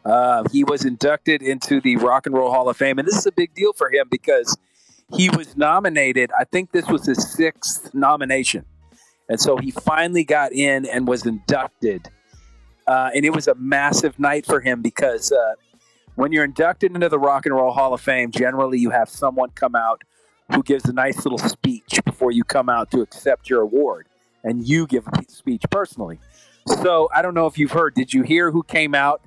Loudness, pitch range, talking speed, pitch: -19 LUFS, 130-195 Hz, 205 wpm, 150 Hz